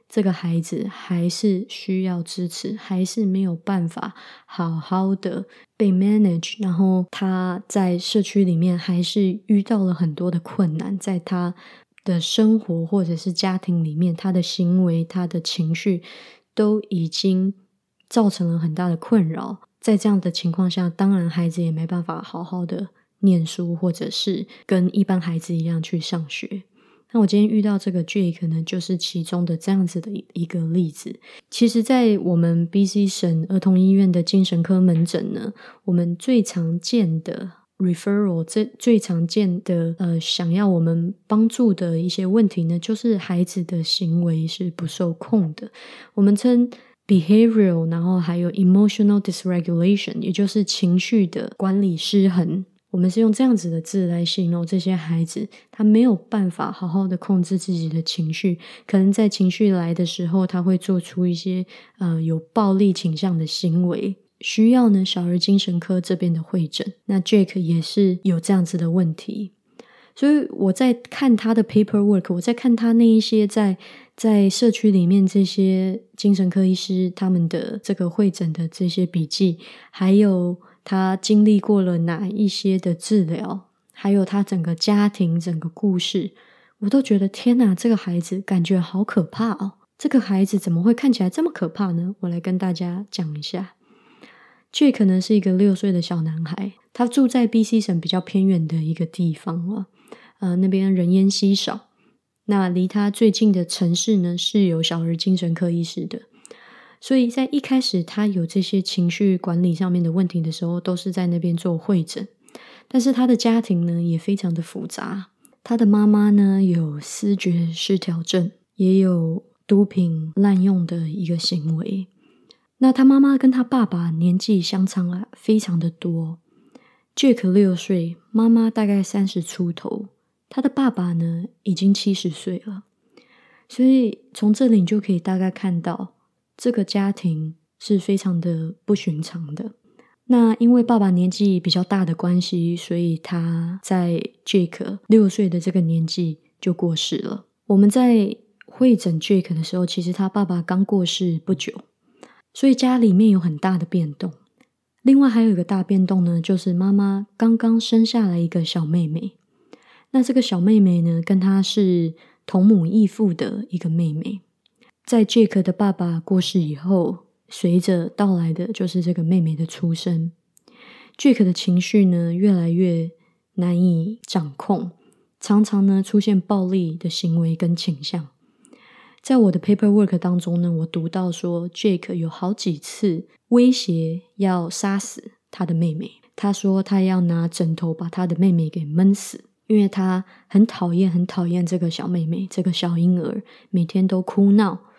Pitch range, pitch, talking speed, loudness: 175-210 Hz, 190 Hz, 260 characters per minute, -20 LUFS